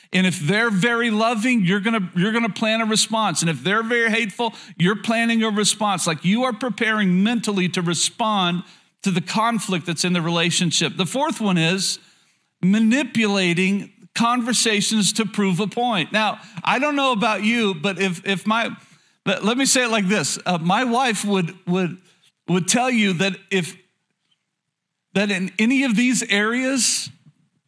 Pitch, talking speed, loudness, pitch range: 200 Hz, 175 wpm, -20 LUFS, 185-225 Hz